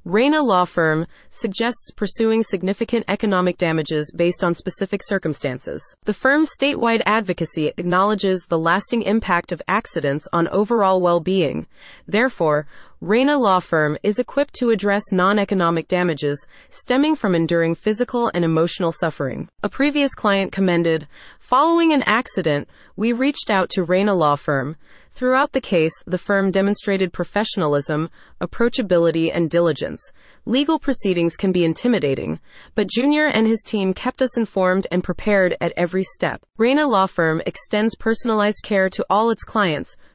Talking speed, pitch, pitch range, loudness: 140 wpm, 195 Hz, 170-225 Hz, -20 LUFS